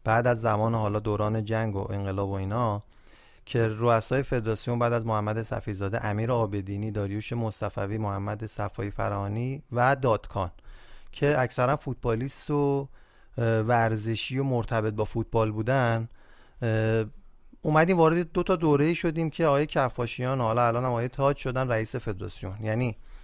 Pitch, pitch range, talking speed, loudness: 115 Hz, 110-130 Hz, 140 wpm, -27 LUFS